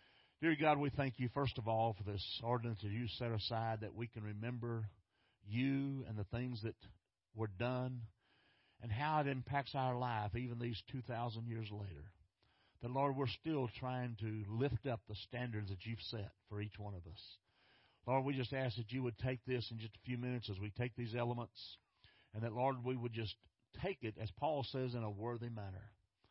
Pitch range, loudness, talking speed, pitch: 105-125 Hz, -42 LUFS, 205 wpm, 115 Hz